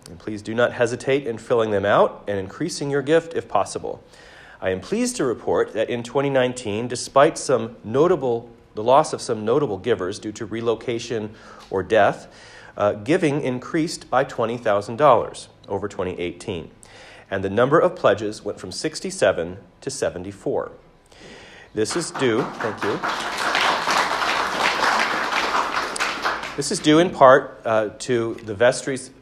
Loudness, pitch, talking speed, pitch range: -21 LUFS, 125 Hz, 140 wpm, 110-150 Hz